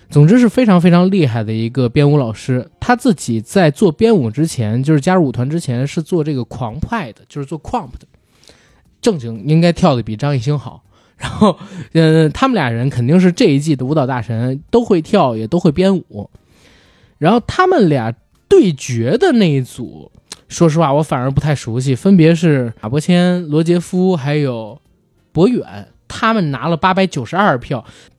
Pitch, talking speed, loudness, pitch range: 150 Hz, 270 characters per minute, -14 LUFS, 125-180 Hz